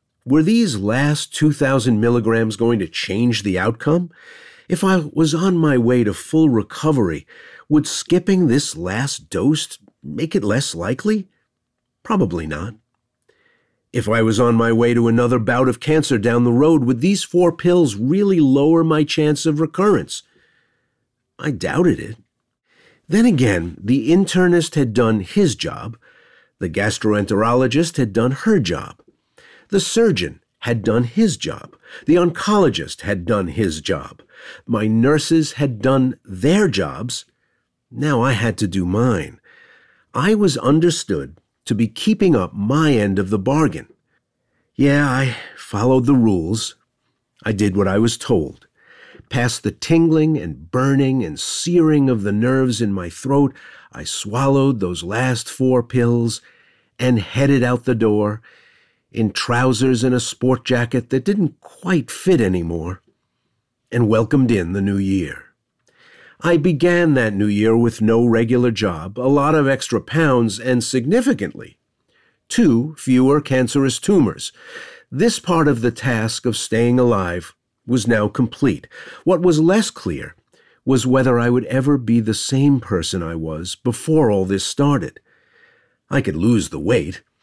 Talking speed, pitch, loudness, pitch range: 145 wpm, 125 Hz, -18 LUFS, 115-155 Hz